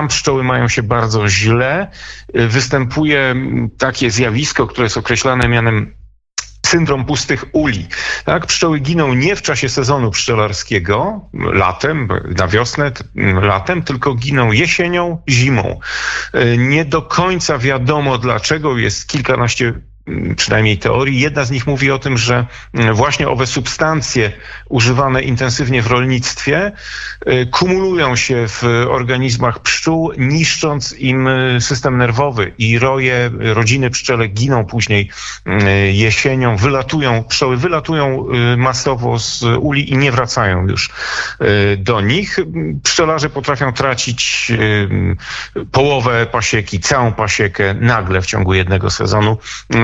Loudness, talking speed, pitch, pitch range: -14 LUFS, 115 wpm, 125 Hz, 115-140 Hz